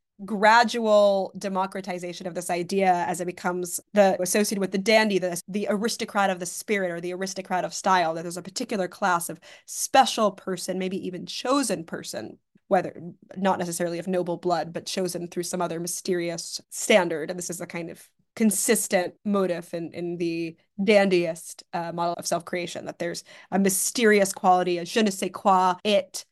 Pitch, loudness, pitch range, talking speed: 185 Hz, -25 LUFS, 175-200 Hz, 175 wpm